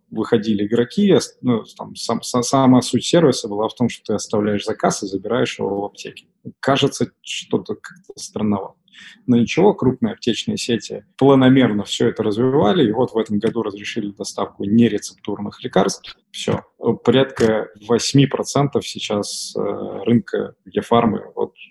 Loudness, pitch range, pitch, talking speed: -19 LUFS, 105-130 Hz, 115 Hz, 140 wpm